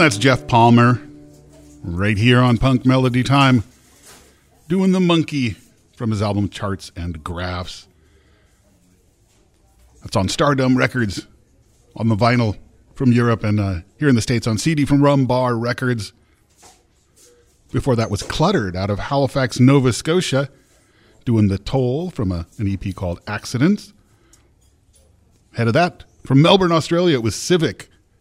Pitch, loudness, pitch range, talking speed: 115 Hz, -18 LUFS, 95-130 Hz, 140 wpm